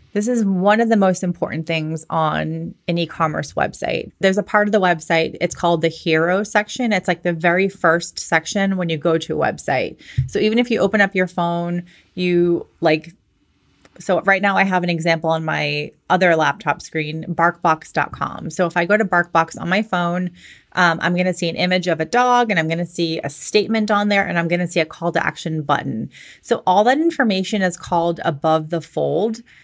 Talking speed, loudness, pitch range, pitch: 210 wpm, -19 LUFS, 165-195 Hz, 175 Hz